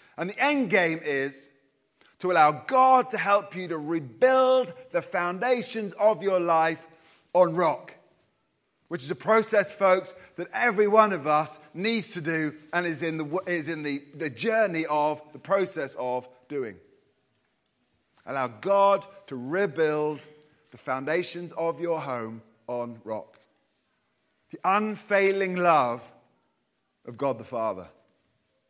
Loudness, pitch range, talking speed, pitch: -26 LUFS, 150-200 Hz, 135 wpm, 170 Hz